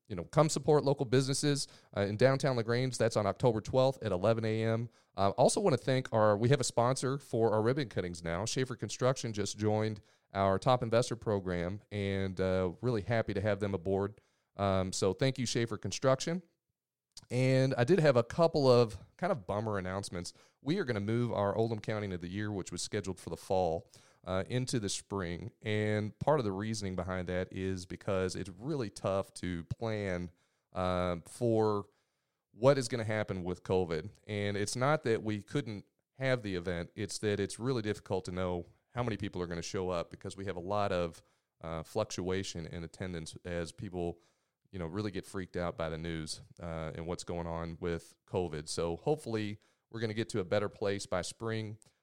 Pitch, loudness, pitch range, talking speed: 105 Hz, -34 LUFS, 95-120 Hz, 200 wpm